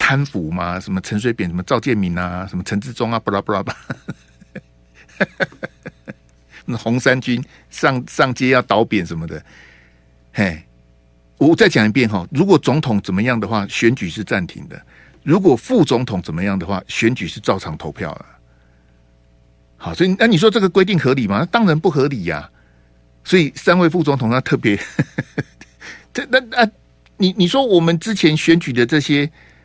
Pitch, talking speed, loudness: 115 Hz, 255 characters per minute, -17 LUFS